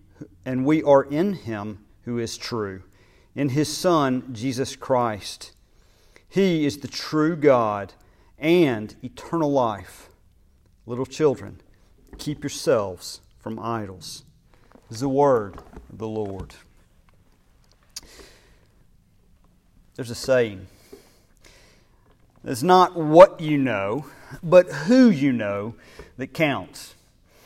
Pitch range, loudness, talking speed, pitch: 100-145 Hz, -22 LUFS, 105 wpm, 120 Hz